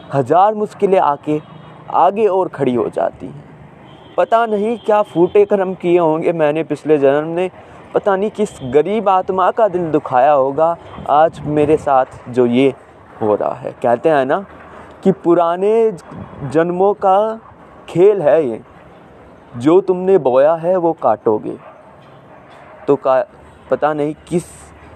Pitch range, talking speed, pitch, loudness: 150-195 Hz, 140 wpm, 165 Hz, -15 LUFS